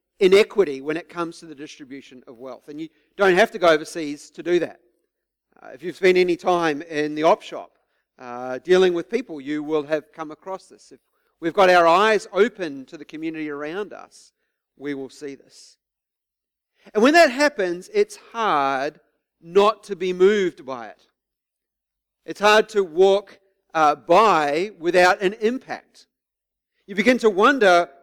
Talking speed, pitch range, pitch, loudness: 170 wpm, 155-200 Hz, 175 Hz, -20 LUFS